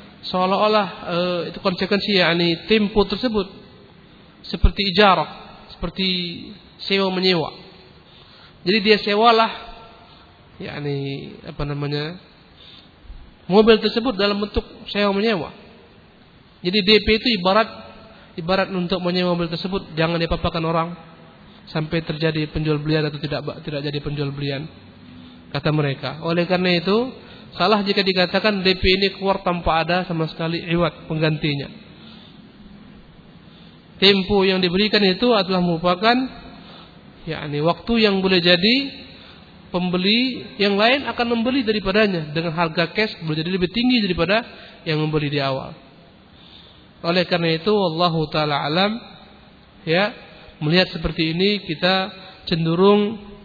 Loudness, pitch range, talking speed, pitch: -20 LUFS, 165-210 Hz, 120 wpm, 185 Hz